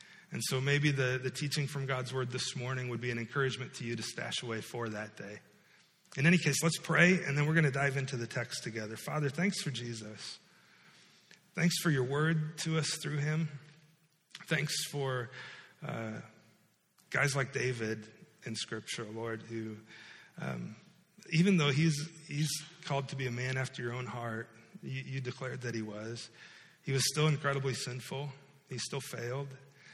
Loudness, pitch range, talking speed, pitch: -34 LUFS, 120-155 Hz, 175 wpm, 135 Hz